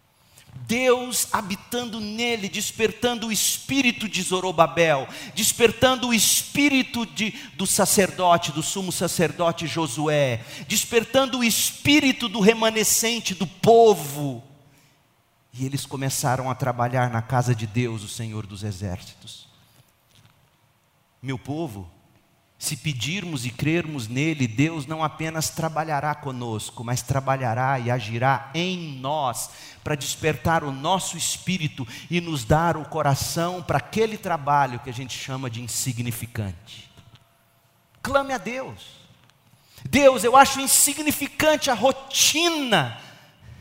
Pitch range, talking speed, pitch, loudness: 130-215 Hz, 115 wpm, 155 Hz, -22 LUFS